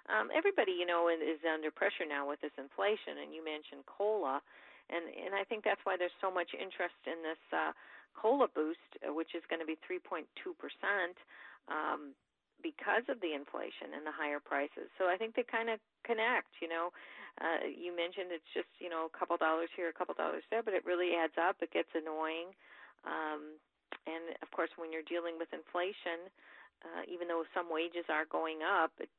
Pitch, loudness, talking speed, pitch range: 170 Hz, -38 LUFS, 195 wpm, 160-185 Hz